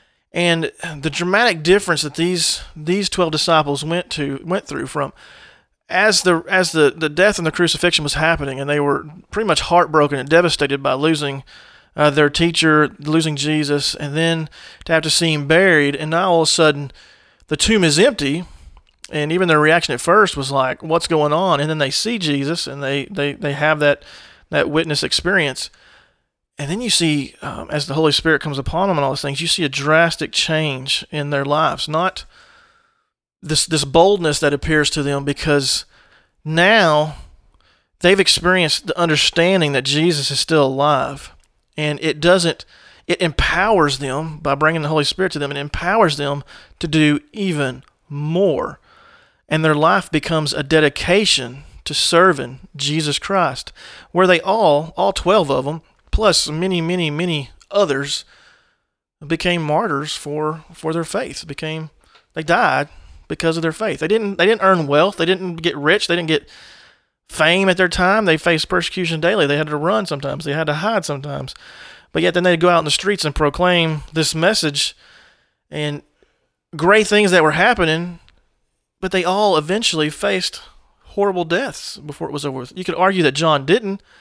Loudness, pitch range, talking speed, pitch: -17 LUFS, 145-180 Hz, 175 wpm, 160 Hz